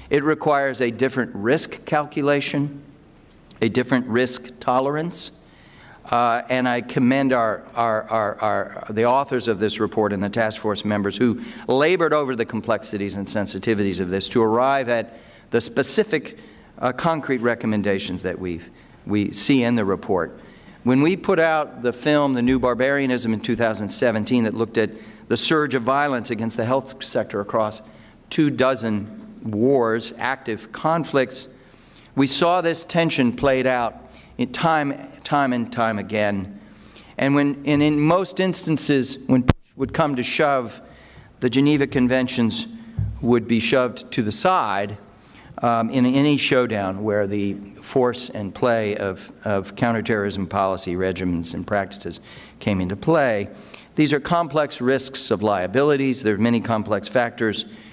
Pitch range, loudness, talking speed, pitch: 110-140 Hz, -21 LUFS, 150 wpm, 125 Hz